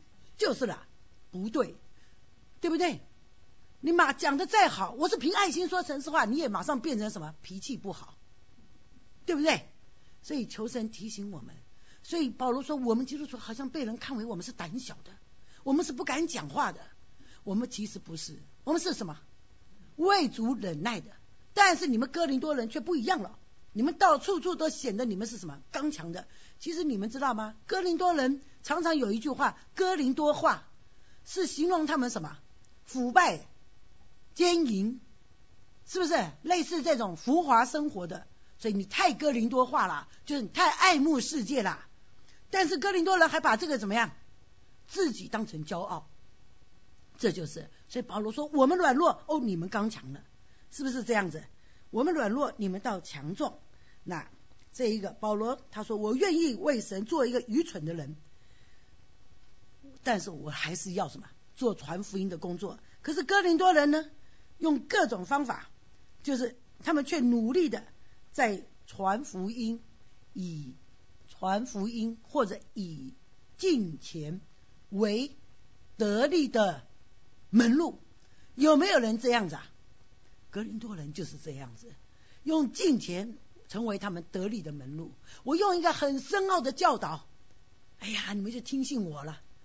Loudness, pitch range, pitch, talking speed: -30 LUFS, 205-315 Hz, 250 Hz, 240 characters per minute